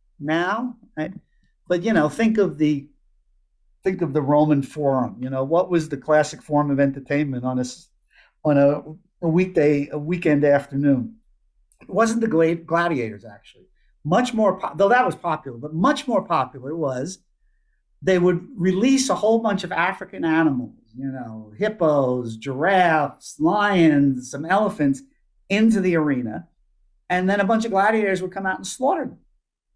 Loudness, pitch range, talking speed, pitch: -21 LUFS, 140-195 Hz, 160 wpm, 160 Hz